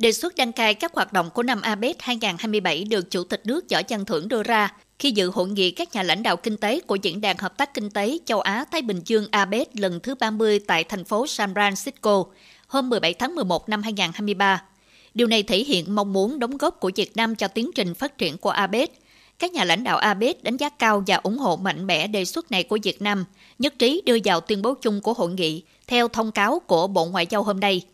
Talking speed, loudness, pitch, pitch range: 245 wpm, -23 LUFS, 210 Hz, 190-240 Hz